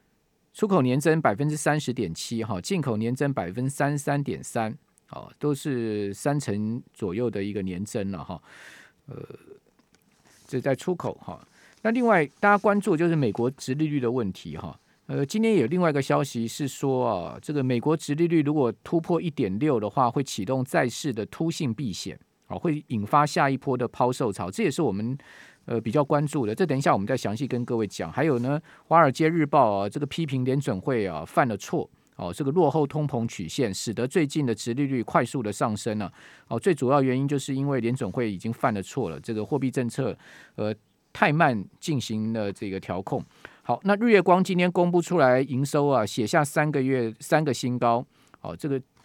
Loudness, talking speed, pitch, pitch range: -25 LUFS, 295 characters per minute, 135 Hz, 115-150 Hz